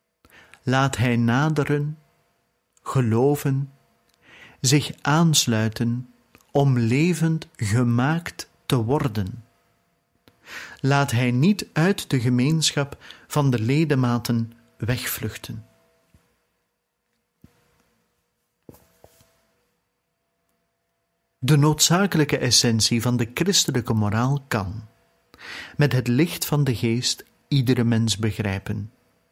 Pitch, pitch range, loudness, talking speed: 125 Hz, 115-145 Hz, -22 LUFS, 80 wpm